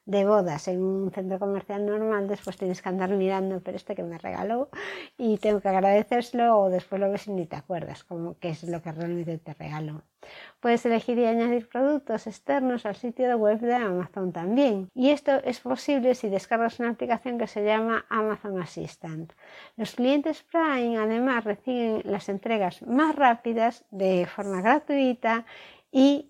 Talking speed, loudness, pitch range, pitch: 170 wpm, -26 LUFS, 190-245 Hz, 215 Hz